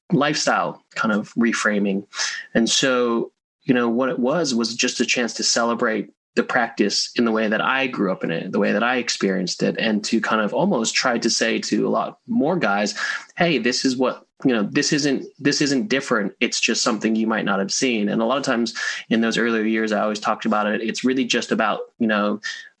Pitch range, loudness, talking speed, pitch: 110-130 Hz, -21 LUFS, 225 wpm, 115 Hz